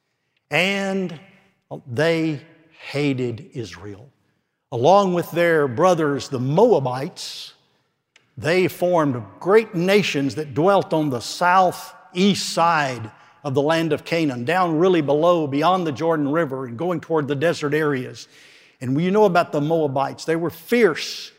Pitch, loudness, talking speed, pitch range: 160 Hz, -20 LUFS, 130 wpm, 145-180 Hz